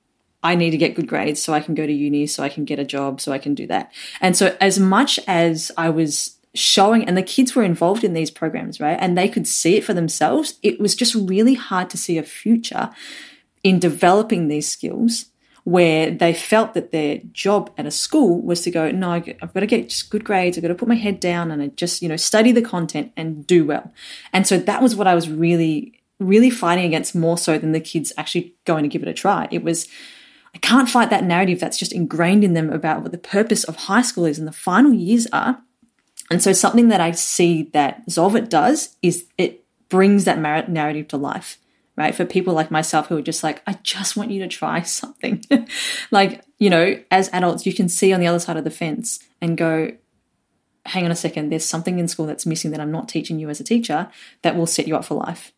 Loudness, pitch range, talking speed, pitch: -19 LUFS, 160-205 Hz, 235 wpm, 175 Hz